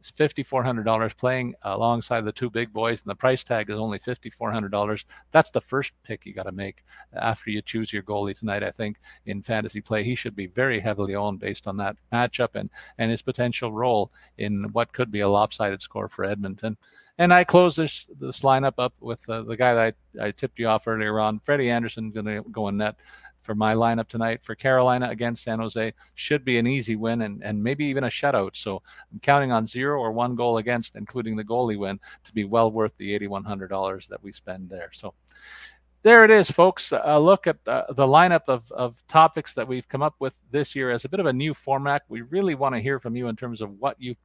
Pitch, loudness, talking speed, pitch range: 115 Hz, -24 LUFS, 230 wpm, 105-130 Hz